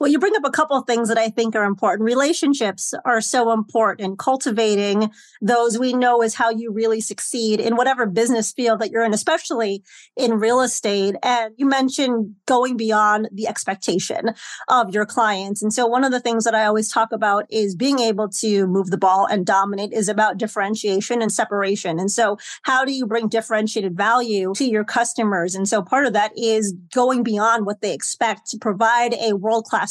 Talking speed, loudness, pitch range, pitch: 200 wpm, -19 LUFS, 210-240 Hz, 225 Hz